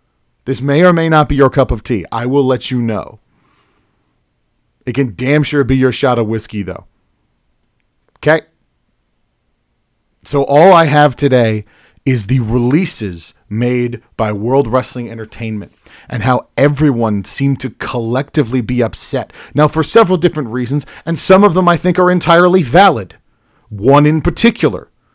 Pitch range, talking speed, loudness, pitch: 115-150 Hz, 155 wpm, -13 LUFS, 130 Hz